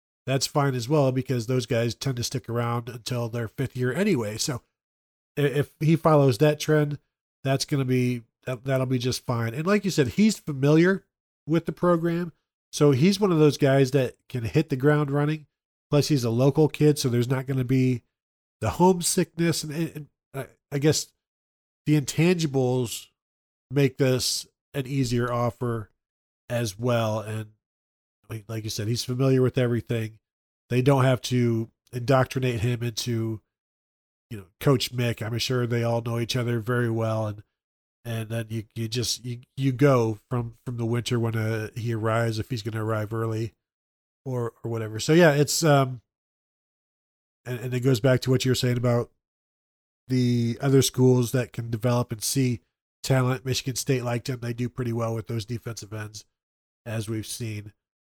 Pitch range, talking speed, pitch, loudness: 115-135 Hz, 175 wpm, 125 Hz, -25 LUFS